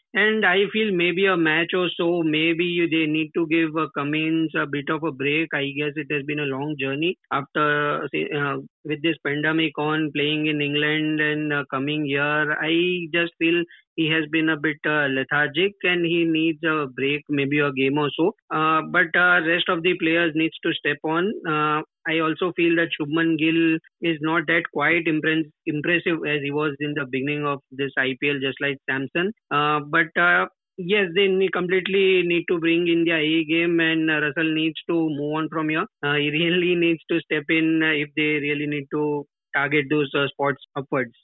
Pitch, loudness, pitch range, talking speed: 155 Hz, -22 LUFS, 150-170 Hz, 200 wpm